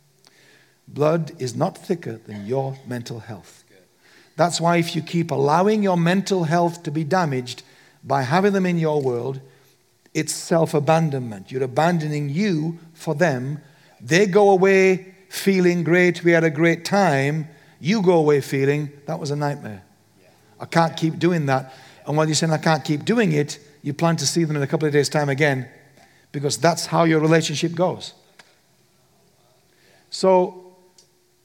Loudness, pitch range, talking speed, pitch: -20 LUFS, 140-175 Hz, 160 wpm, 155 Hz